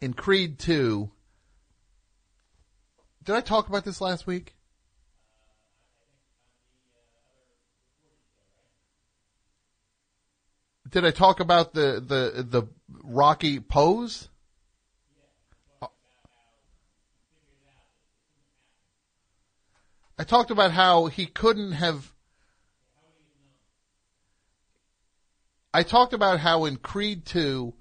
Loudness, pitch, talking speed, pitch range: -23 LUFS, 125 Hz, 70 wpm, 100-165 Hz